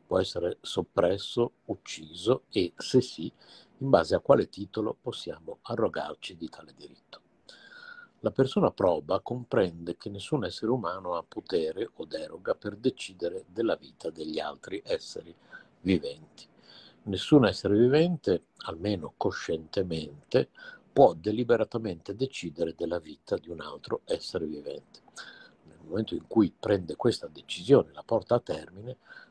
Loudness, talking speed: -29 LUFS, 125 wpm